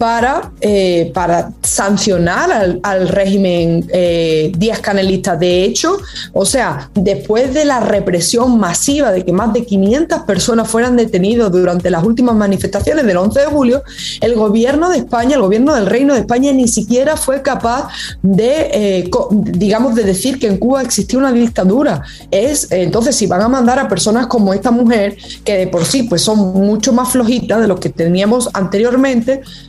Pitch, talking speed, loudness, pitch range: 215 Hz, 175 wpm, -13 LUFS, 190-250 Hz